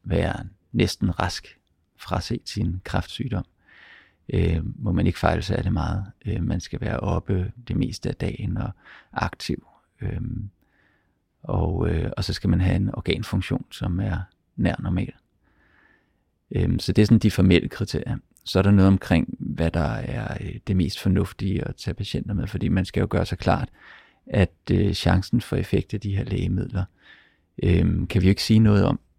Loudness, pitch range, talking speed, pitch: -24 LUFS, 90-110 Hz, 180 wpm, 100 Hz